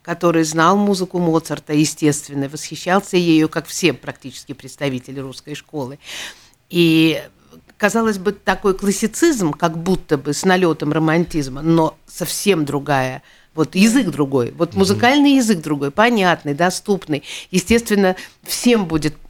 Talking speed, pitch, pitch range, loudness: 120 wpm, 165 Hz, 145-195 Hz, -17 LUFS